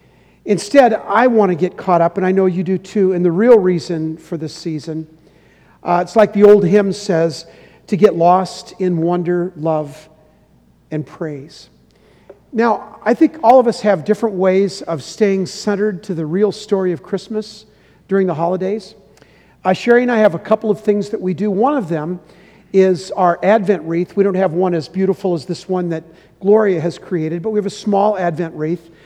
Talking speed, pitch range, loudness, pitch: 195 wpm, 170-210 Hz, -16 LUFS, 185 Hz